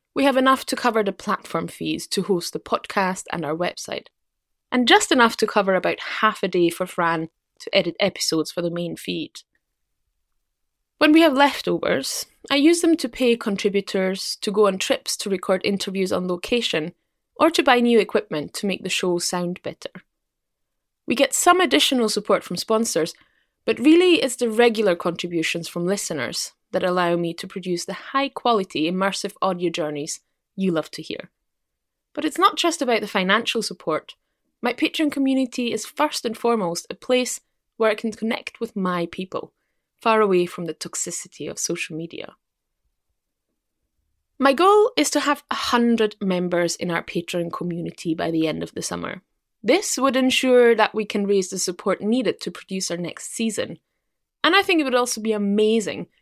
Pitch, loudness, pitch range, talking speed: 210 Hz, -21 LUFS, 180-255 Hz, 175 wpm